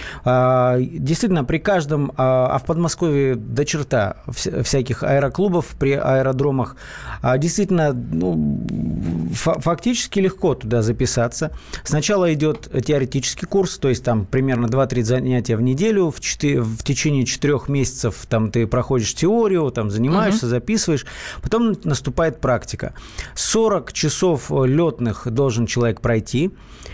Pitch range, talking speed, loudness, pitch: 120-165 Hz, 120 wpm, -19 LUFS, 135 Hz